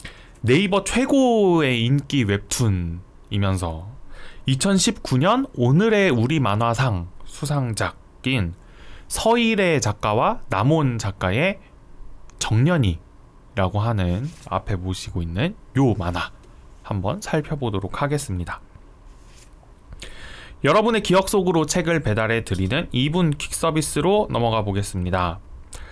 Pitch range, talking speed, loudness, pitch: 95-155 Hz, 225 characters per minute, -21 LUFS, 120 Hz